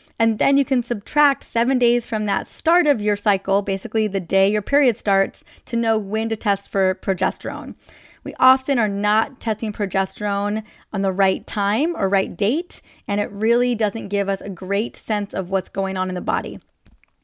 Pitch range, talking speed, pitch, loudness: 195-240 Hz, 190 wpm, 210 Hz, -21 LUFS